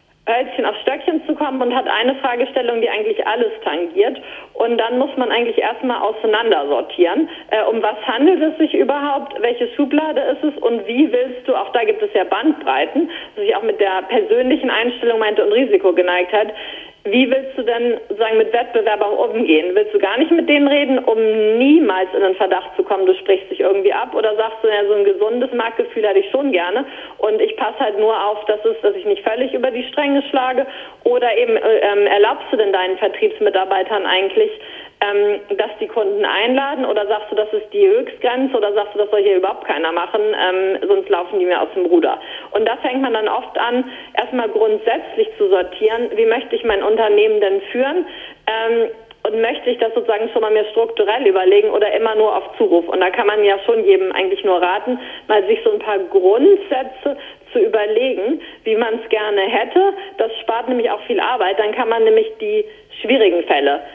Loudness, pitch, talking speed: -17 LUFS, 255 Hz, 205 wpm